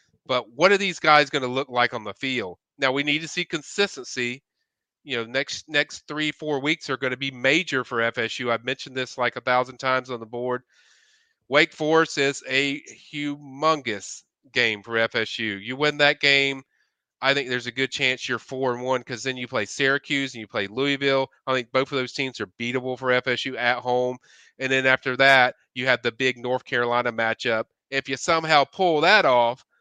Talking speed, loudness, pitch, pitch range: 205 wpm, -23 LUFS, 130 Hz, 125-145 Hz